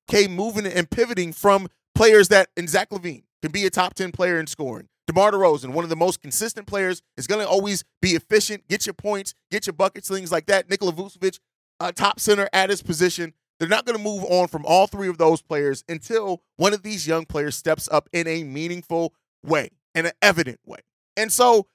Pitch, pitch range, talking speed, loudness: 185 Hz, 165-200 Hz, 220 wpm, -21 LUFS